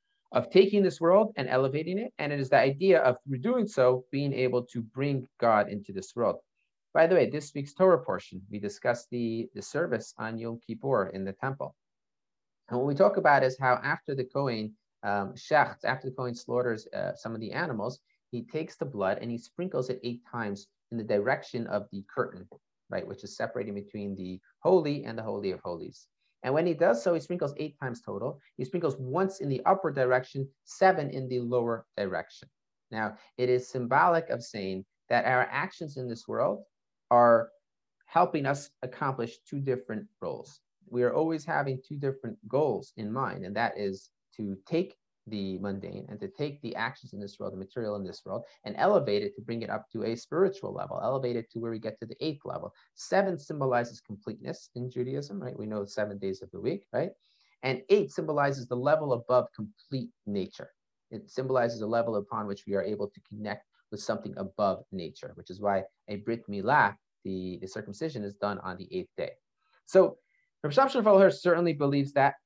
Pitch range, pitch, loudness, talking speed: 110-155 Hz, 125 Hz, -30 LUFS, 200 wpm